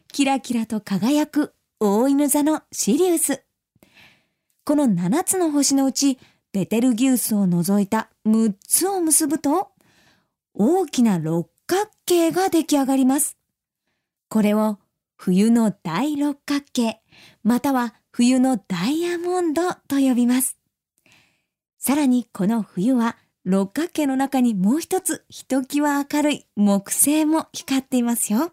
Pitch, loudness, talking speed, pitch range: 265 Hz, -21 LUFS, 235 characters per minute, 220-295 Hz